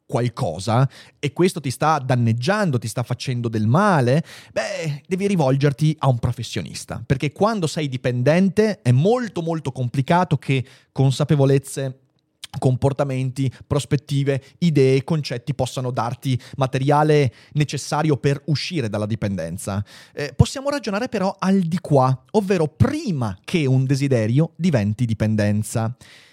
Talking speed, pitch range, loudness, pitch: 120 wpm, 125-160 Hz, -21 LUFS, 140 Hz